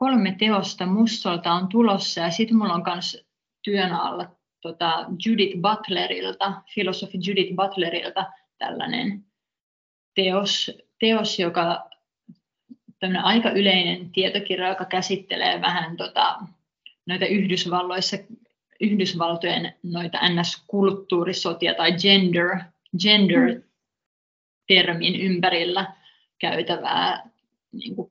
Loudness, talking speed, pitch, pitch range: -22 LUFS, 90 wpm, 190 Hz, 175-200 Hz